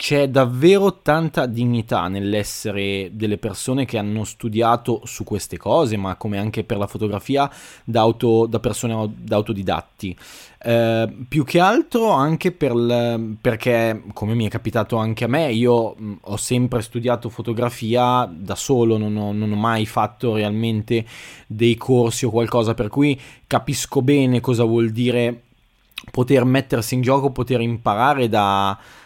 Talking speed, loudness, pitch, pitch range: 145 wpm, -20 LUFS, 115 Hz, 110-125 Hz